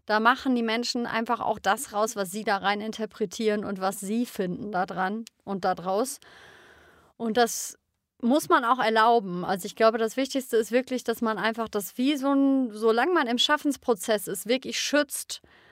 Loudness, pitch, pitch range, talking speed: -26 LUFS, 225 Hz, 210-250 Hz, 180 wpm